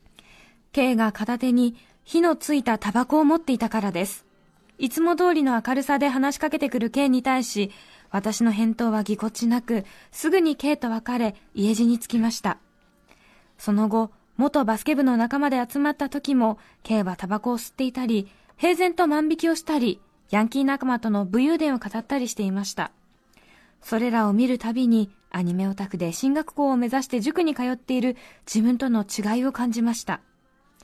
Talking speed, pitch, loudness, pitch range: 340 characters per minute, 240 Hz, -24 LUFS, 220-280 Hz